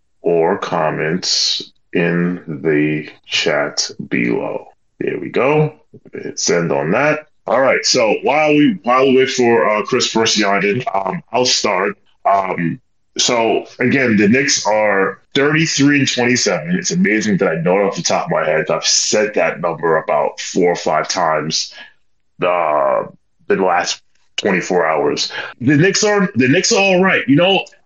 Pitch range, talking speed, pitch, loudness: 105-155 Hz, 165 wpm, 130 Hz, -15 LUFS